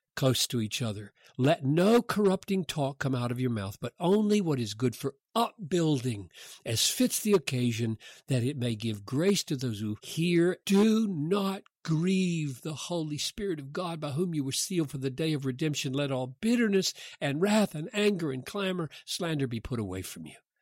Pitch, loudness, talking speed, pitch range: 150 Hz, -29 LUFS, 190 wpm, 130-190 Hz